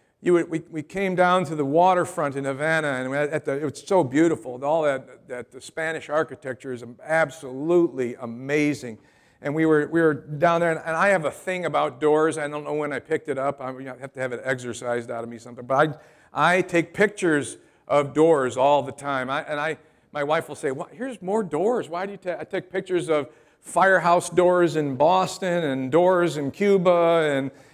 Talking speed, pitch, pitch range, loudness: 215 wpm, 155 Hz, 140-170 Hz, -23 LUFS